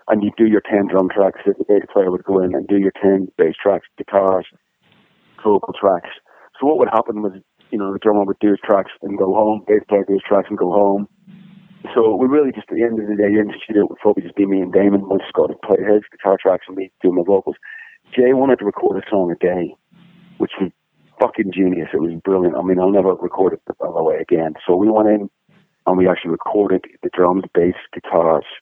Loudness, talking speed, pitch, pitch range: -17 LUFS, 240 wpm, 100 Hz, 95-110 Hz